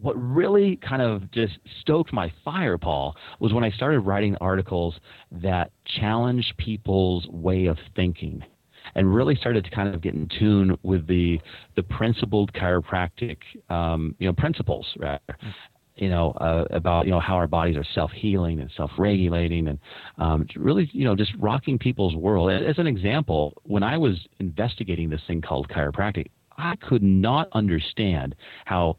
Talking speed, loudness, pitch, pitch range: 170 wpm, -24 LUFS, 95 Hz, 85-110 Hz